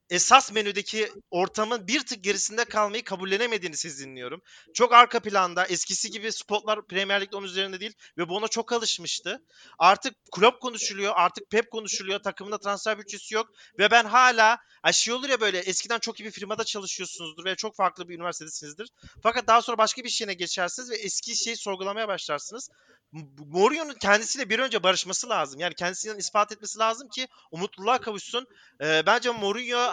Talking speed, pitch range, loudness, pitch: 170 wpm, 190-230 Hz, -25 LUFS, 210 Hz